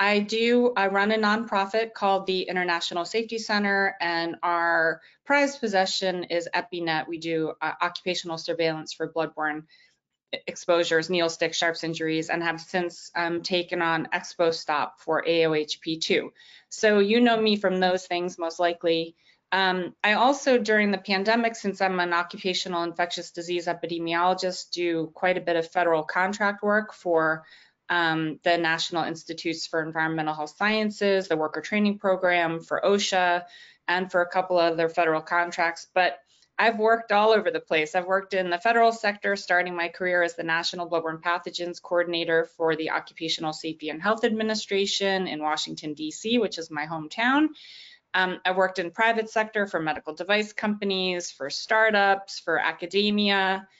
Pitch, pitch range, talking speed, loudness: 175 Hz, 165-200 Hz, 155 wpm, -25 LUFS